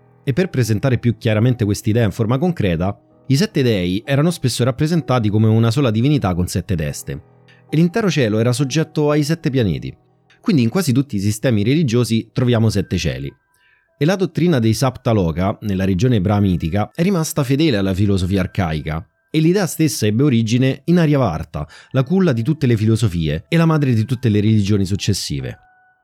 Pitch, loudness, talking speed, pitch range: 125 Hz, -17 LUFS, 175 wpm, 105-150 Hz